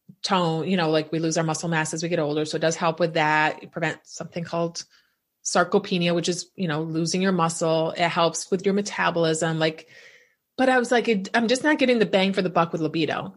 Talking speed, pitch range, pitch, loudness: 230 wpm, 160-195 Hz, 170 Hz, -23 LUFS